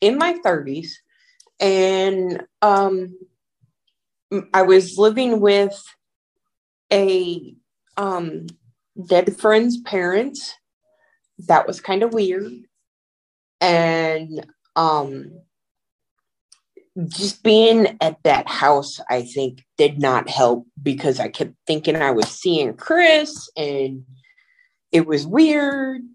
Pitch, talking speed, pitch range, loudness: 190 Hz, 100 wpm, 150-225 Hz, -18 LUFS